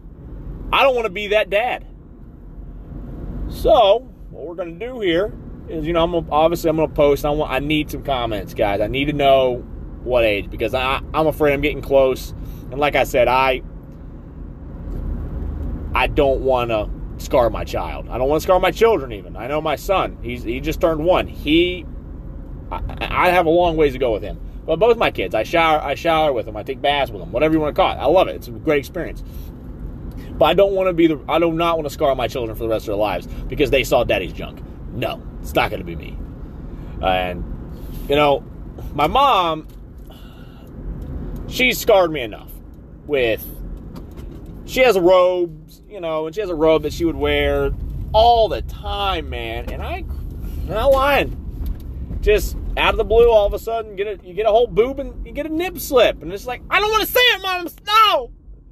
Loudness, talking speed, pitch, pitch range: -18 LUFS, 215 wpm, 155 Hz, 120-200 Hz